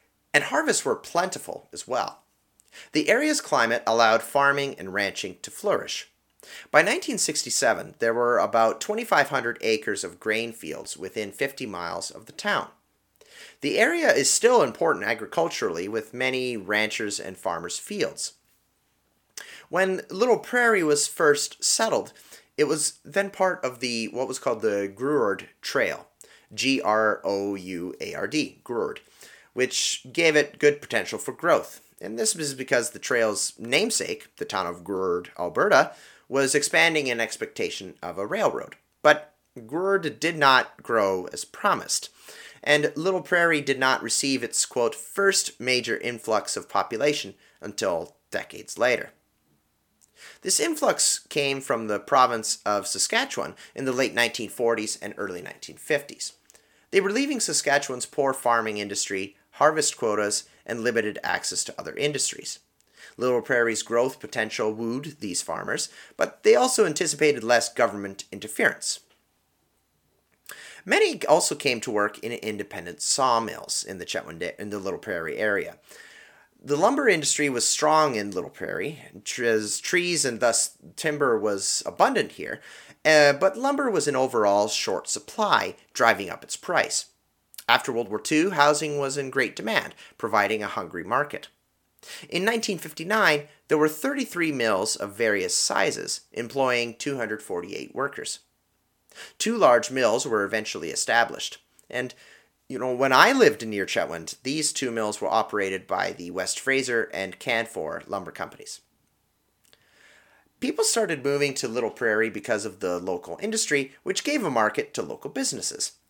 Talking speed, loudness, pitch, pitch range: 145 wpm, -24 LUFS, 135 Hz, 115-160 Hz